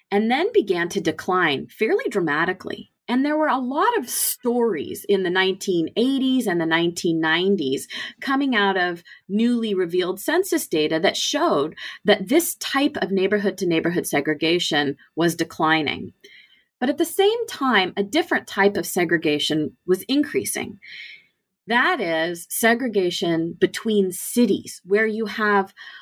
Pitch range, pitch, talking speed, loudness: 175-265 Hz, 200 Hz, 135 wpm, -21 LUFS